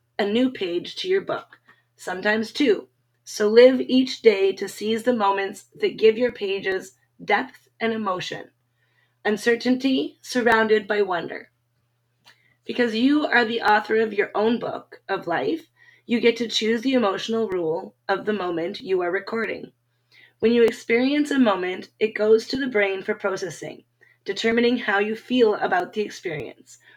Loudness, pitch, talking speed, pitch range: -22 LUFS, 215 Hz, 155 wpm, 190-240 Hz